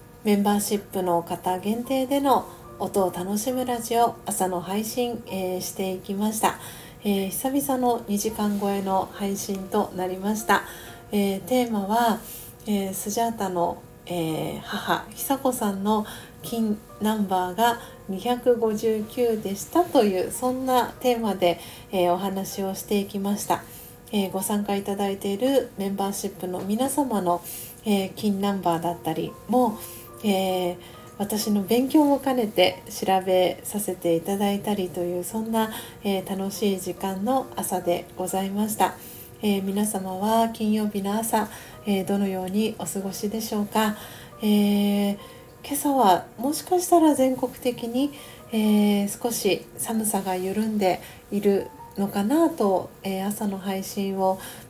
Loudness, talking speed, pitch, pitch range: -25 LUFS, 270 characters per minute, 205 Hz, 190-225 Hz